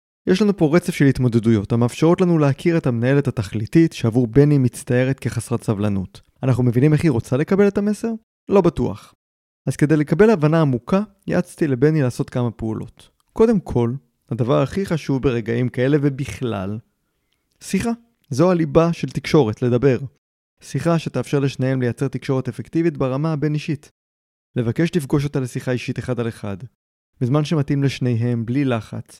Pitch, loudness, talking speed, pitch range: 135 Hz, -19 LUFS, 150 wpm, 120-160 Hz